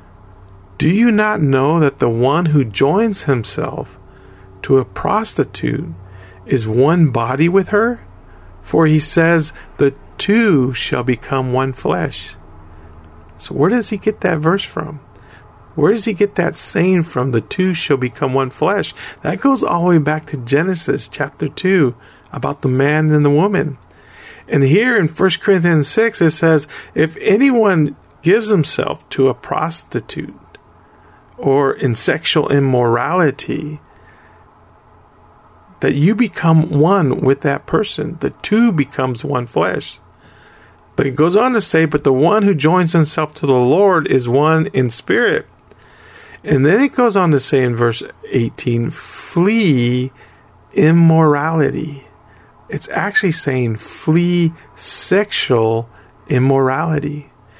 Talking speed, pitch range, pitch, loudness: 140 wpm, 125-170 Hz, 145 Hz, -15 LUFS